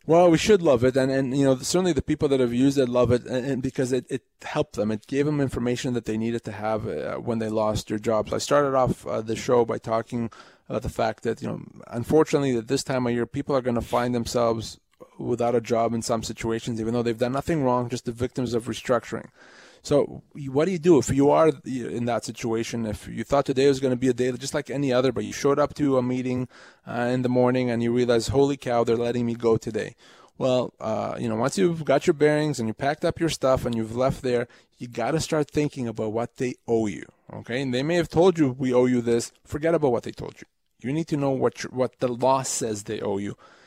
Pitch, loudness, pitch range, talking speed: 125 Hz, -24 LUFS, 115-140 Hz, 255 wpm